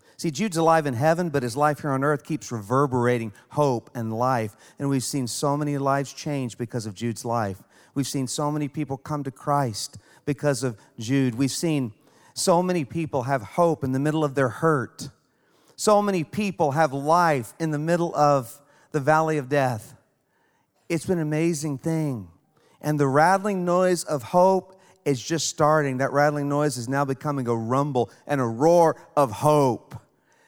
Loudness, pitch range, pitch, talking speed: -24 LUFS, 130-160 Hz, 145 Hz, 180 wpm